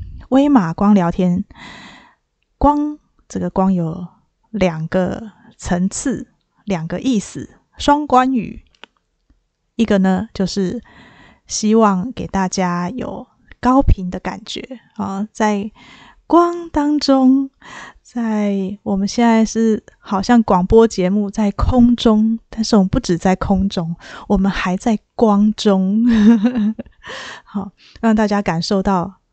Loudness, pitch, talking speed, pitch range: -16 LUFS, 210 Hz, 165 characters per minute, 190-240 Hz